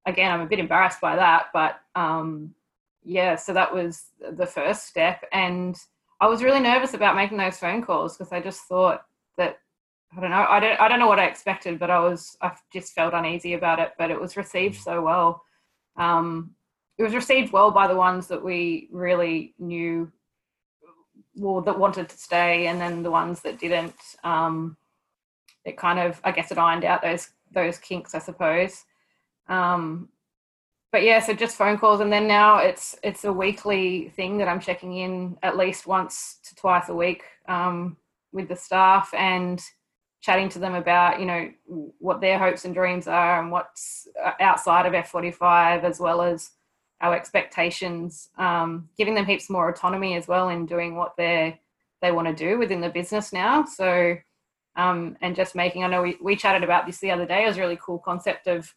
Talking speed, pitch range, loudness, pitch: 195 wpm, 170-190 Hz, -23 LUFS, 180 Hz